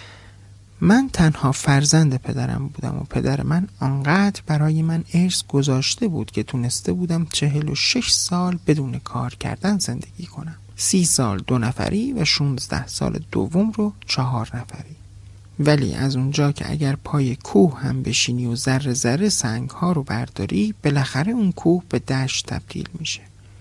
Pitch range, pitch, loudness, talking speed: 120-165 Hz, 140 Hz, -21 LUFS, 150 wpm